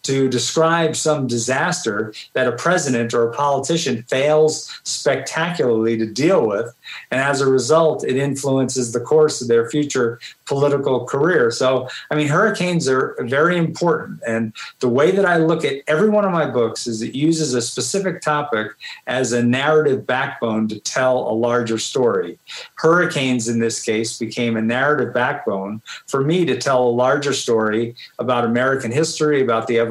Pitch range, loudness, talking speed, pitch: 120-155 Hz, -18 LUFS, 165 wpm, 130 Hz